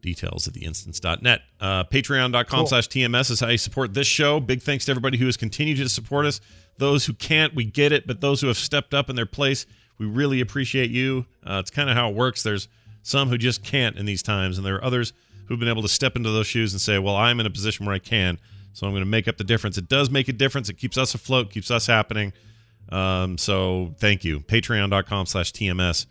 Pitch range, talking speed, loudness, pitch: 100-130 Hz, 245 wpm, -22 LUFS, 115 Hz